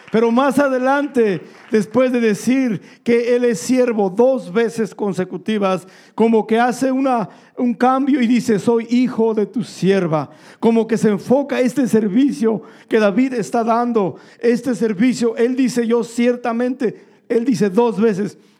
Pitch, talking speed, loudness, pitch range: 235 Hz, 150 wpm, -17 LUFS, 215-250 Hz